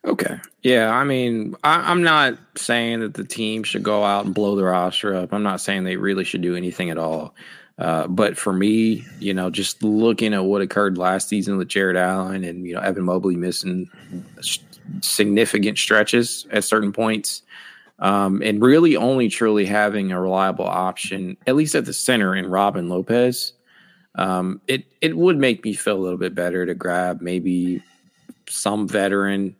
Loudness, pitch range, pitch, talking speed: -20 LUFS, 90-110 Hz, 100 Hz, 180 wpm